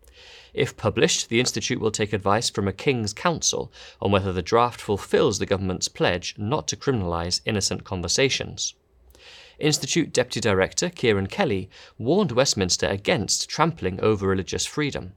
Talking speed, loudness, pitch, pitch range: 140 wpm, -23 LUFS, 105 Hz, 95-120 Hz